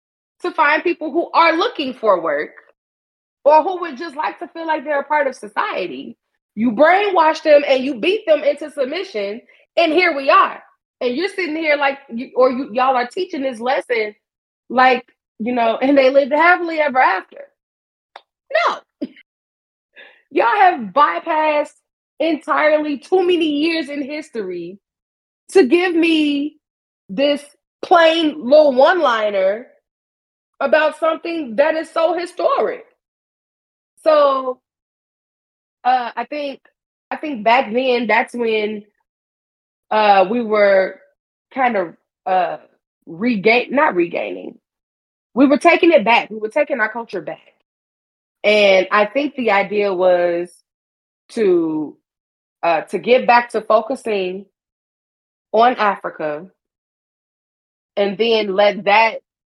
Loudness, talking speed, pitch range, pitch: -16 LUFS, 130 wpm, 220-315 Hz, 280 Hz